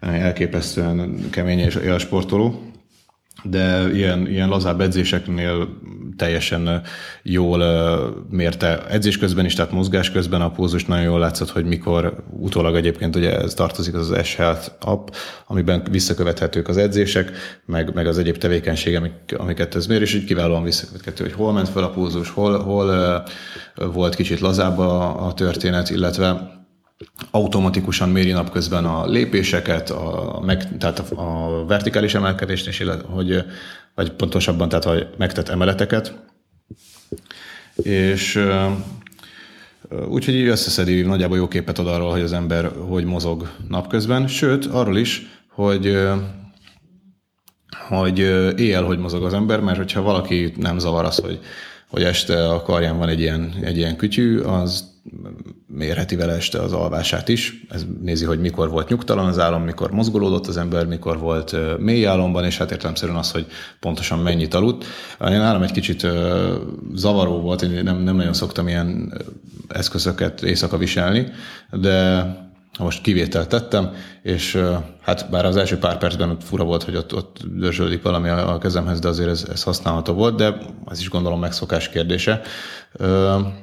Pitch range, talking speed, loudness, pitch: 85-95 Hz, 150 wpm, -20 LUFS, 90 Hz